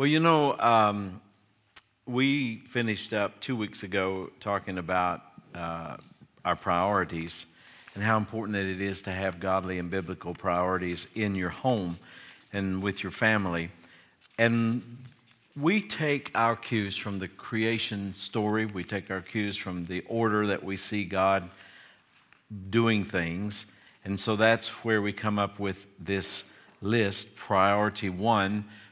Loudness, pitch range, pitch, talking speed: -29 LUFS, 95-110 Hz, 100 Hz, 140 wpm